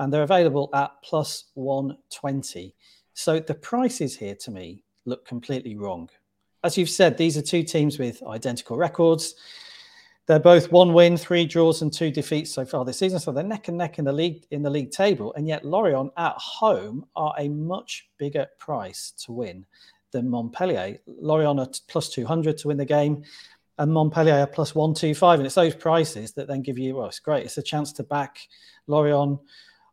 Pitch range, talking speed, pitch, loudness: 135-165 Hz, 190 wpm, 150 Hz, -23 LUFS